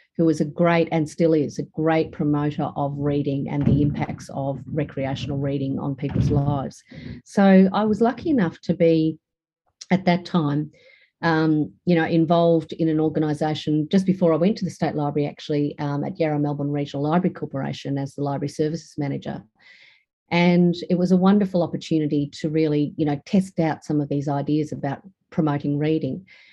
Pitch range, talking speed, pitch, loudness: 145-170 Hz, 175 wpm, 155 Hz, -22 LUFS